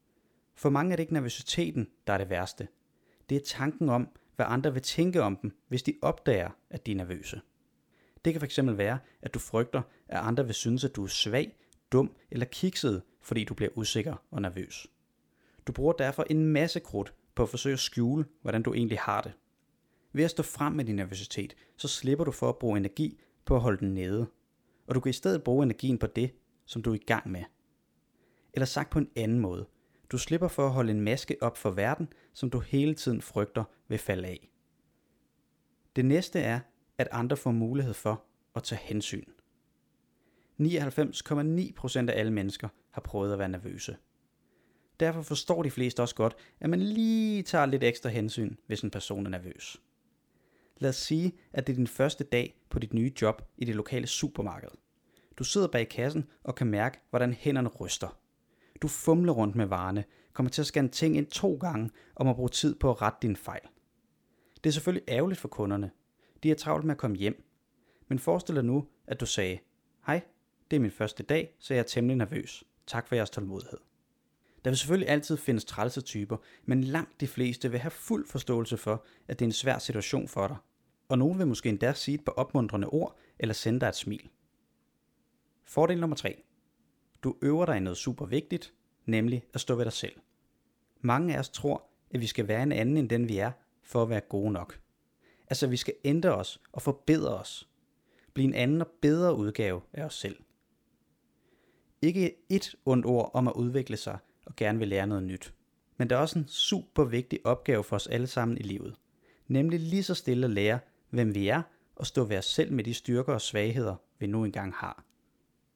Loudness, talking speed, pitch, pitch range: -31 LUFS, 200 wpm, 125 Hz, 110-145 Hz